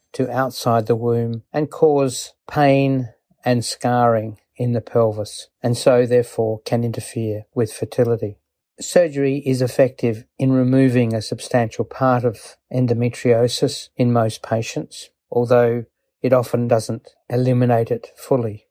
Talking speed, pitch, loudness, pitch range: 125 wpm, 120 Hz, -19 LUFS, 115-130 Hz